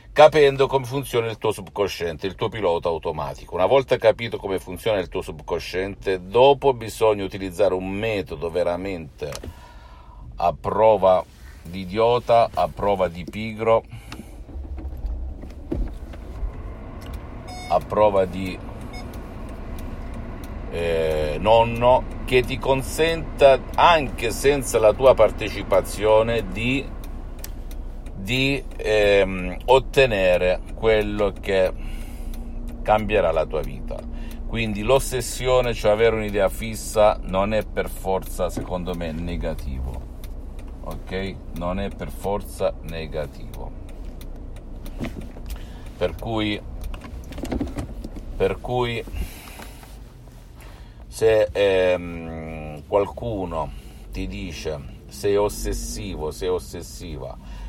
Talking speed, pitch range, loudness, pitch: 90 wpm, 80-110 Hz, -22 LUFS, 95 Hz